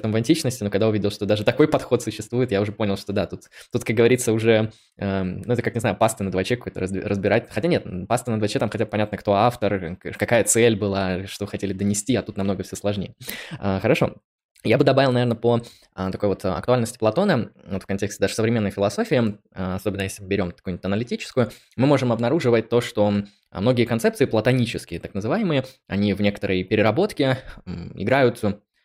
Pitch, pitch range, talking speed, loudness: 105 Hz, 100-120 Hz, 190 wpm, -22 LUFS